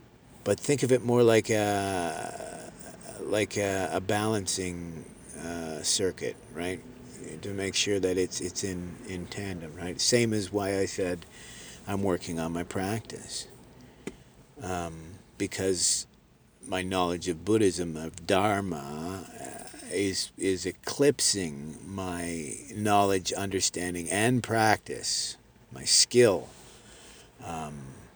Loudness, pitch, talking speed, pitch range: -28 LUFS, 95 Hz, 115 wpm, 85-105 Hz